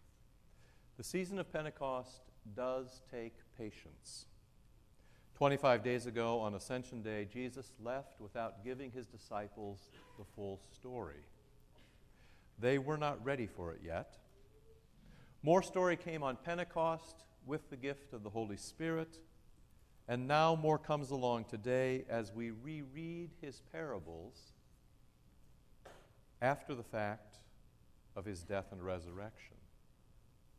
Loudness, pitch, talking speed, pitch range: -40 LUFS, 120 Hz, 120 wpm, 105-140 Hz